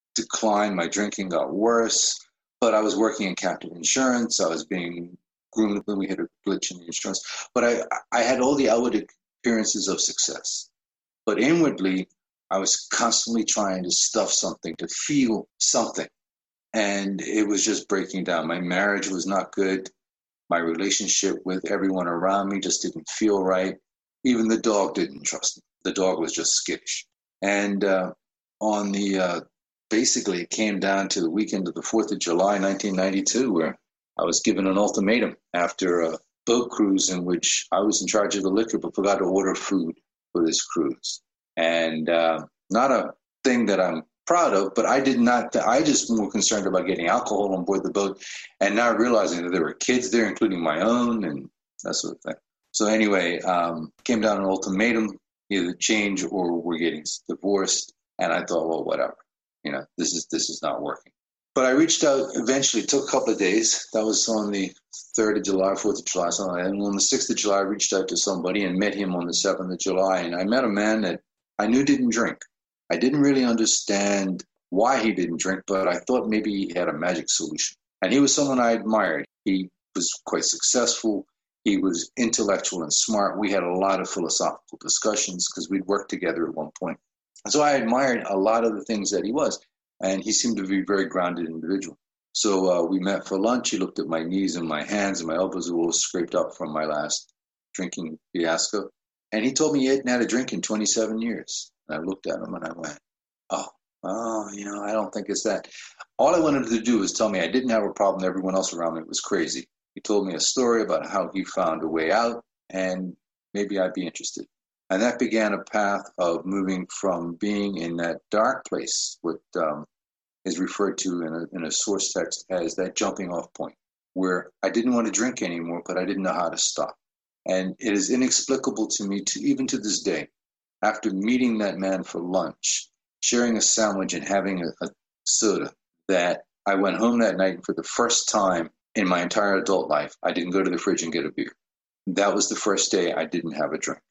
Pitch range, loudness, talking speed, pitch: 95-110 Hz, -24 LUFS, 210 wpm, 100 Hz